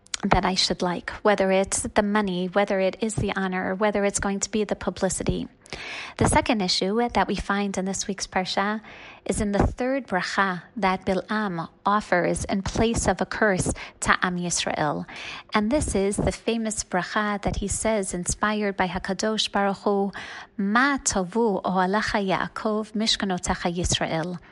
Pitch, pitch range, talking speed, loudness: 200 Hz, 185-215 Hz, 160 wpm, -24 LUFS